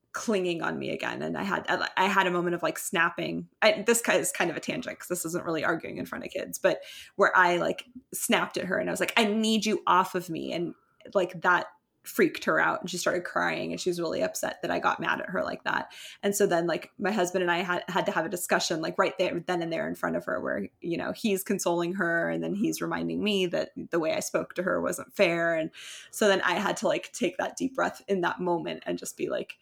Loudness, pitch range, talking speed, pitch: -28 LUFS, 170-200 Hz, 270 wpm, 180 Hz